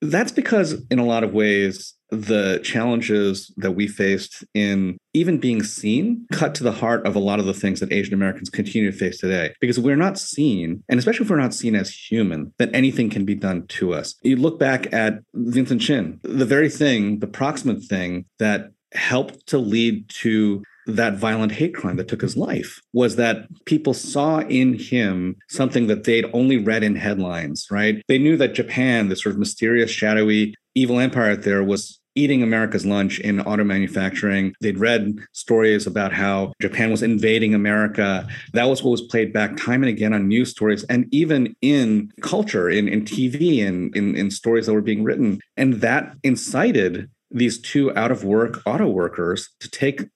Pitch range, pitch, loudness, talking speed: 105-130 Hz, 110 Hz, -20 LUFS, 190 wpm